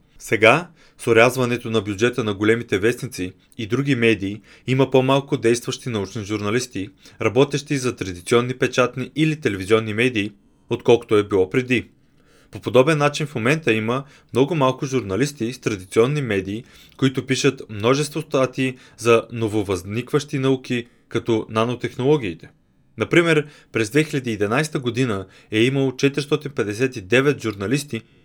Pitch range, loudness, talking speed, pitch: 110-135 Hz, -20 LUFS, 120 wpm, 125 Hz